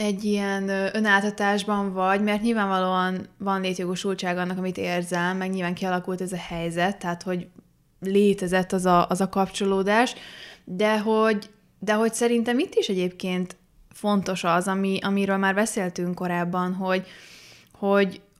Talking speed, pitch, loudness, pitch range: 135 wpm, 190 Hz, -24 LUFS, 180-205 Hz